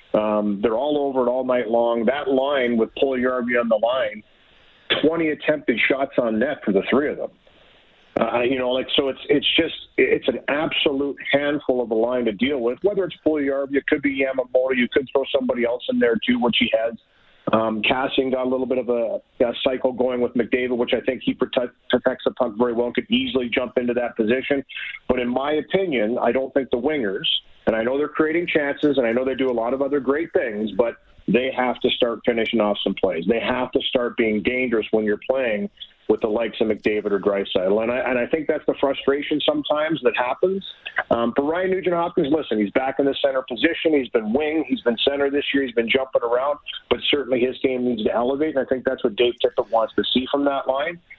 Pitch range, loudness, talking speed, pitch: 120-145 Hz, -21 LUFS, 230 wpm, 130 Hz